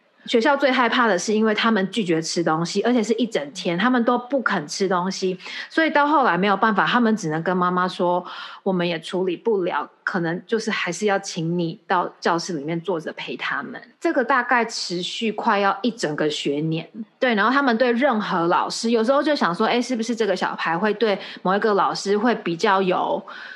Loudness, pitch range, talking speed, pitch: -21 LUFS, 180-240 Hz, 310 characters per minute, 215 Hz